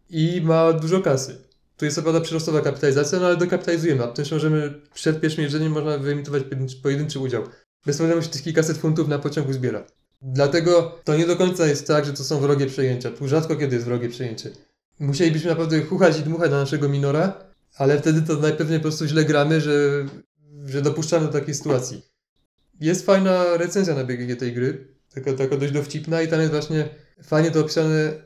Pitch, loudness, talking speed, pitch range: 150 Hz, -21 LUFS, 190 wpm, 140-165 Hz